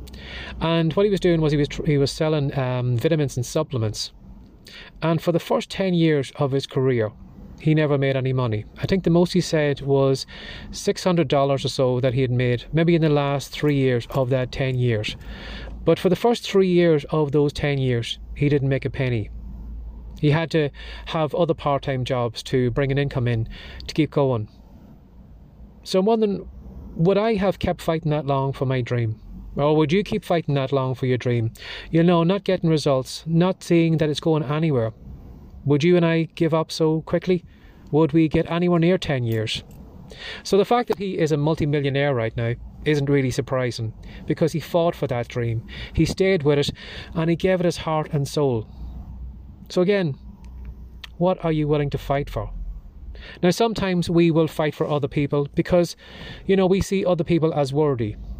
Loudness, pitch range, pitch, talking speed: -22 LUFS, 120-165 Hz, 145 Hz, 195 wpm